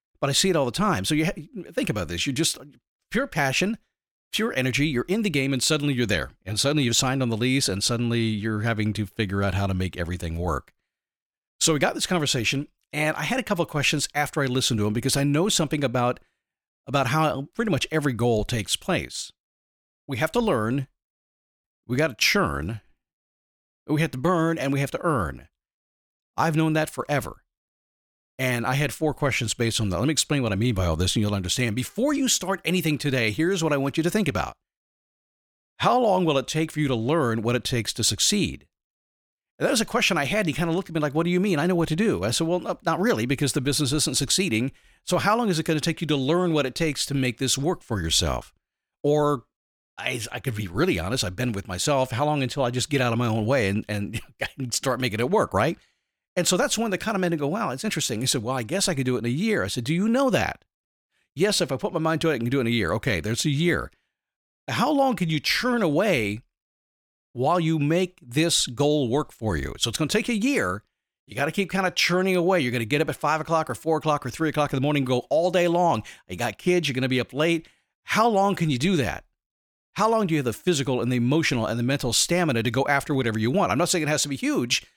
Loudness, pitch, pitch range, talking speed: -24 LUFS, 140 Hz, 120-165 Hz, 265 wpm